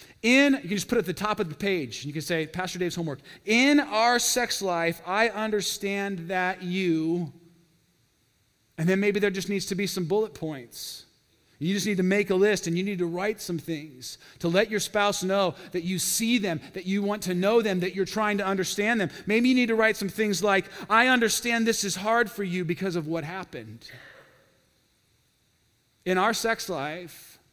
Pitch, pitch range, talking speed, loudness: 195 Hz, 170-210 Hz, 210 wpm, -25 LUFS